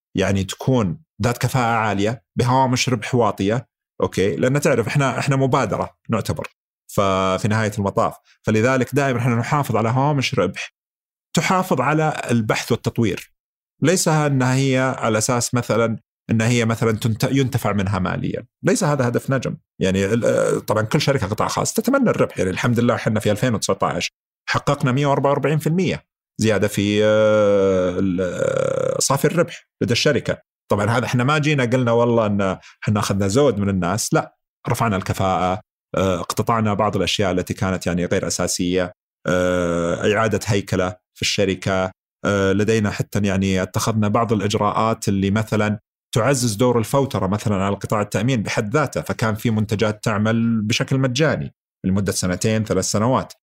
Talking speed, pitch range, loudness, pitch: 135 wpm, 100-130 Hz, -20 LUFS, 110 Hz